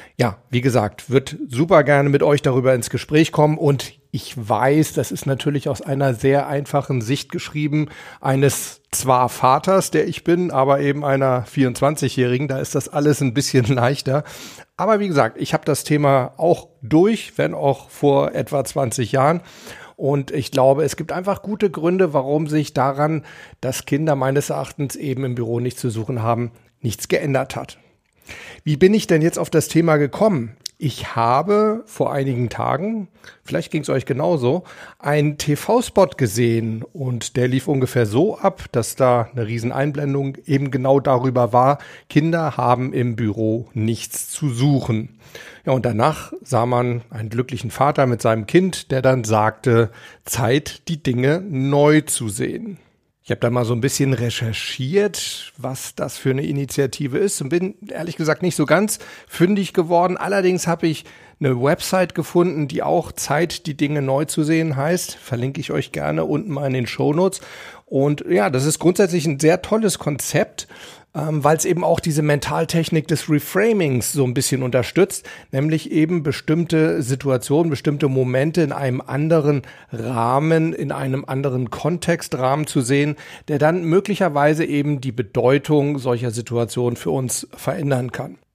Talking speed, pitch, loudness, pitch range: 165 wpm, 140 Hz, -19 LUFS, 130-160 Hz